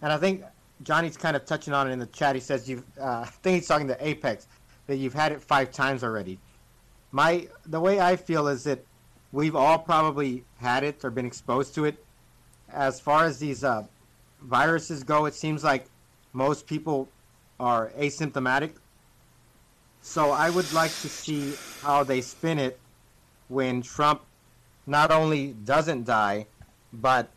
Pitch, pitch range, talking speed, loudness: 140 Hz, 125-155 Hz, 165 wpm, -26 LUFS